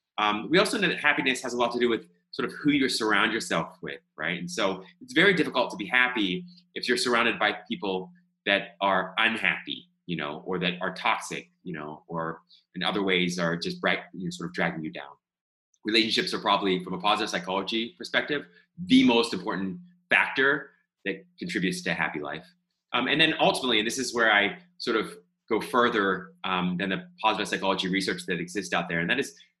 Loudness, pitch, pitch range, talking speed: -26 LUFS, 105 Hz, 90-125 Hz, 205 wpm